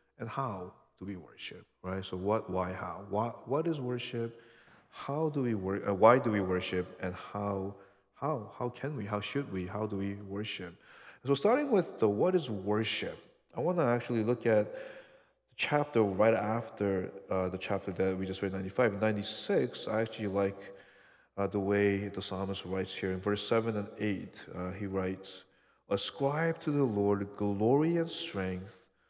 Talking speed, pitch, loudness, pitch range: 180 wpm, 105 Hz, -33 LUFS, 95-120 Hz